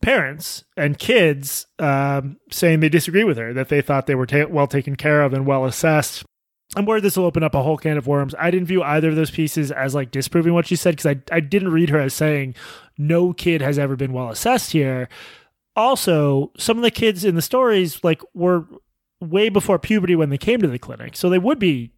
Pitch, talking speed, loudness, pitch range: 155 Hz, 230 wpm, -19 LUFS, 140-180 Hz